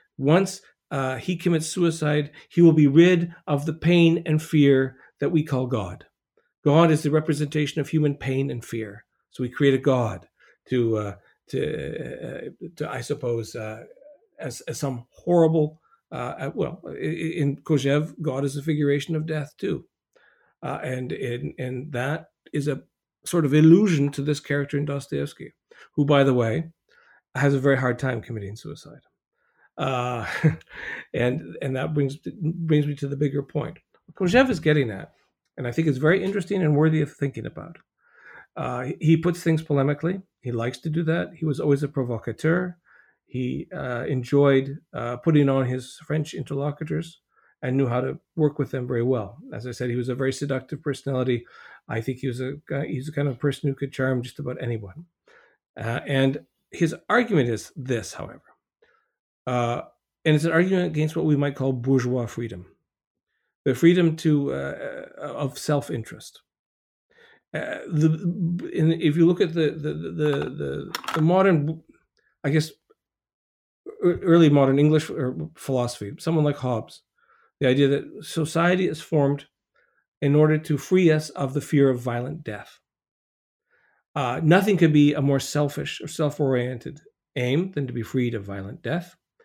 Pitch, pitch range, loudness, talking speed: 145 Hz, 130-160 Hz, -24 LUFS, 165 wpm